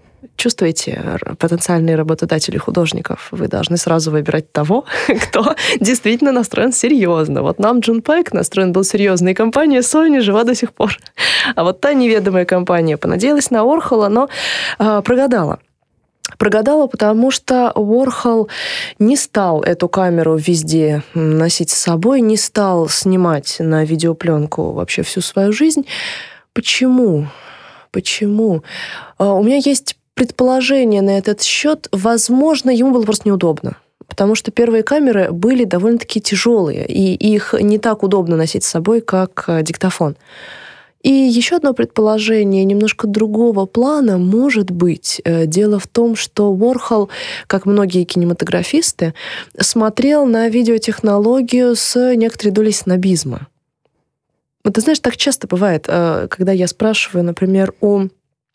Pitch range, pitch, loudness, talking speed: 175-240 Hz, 210 Hz, -14 LUFS, 130 wpm